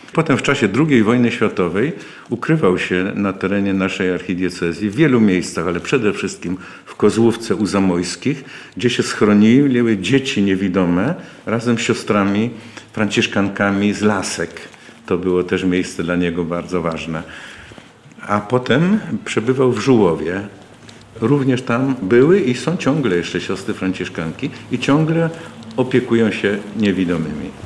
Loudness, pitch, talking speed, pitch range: -17 LUFS, 105 Hz, 130 wpm, 90-120 Hz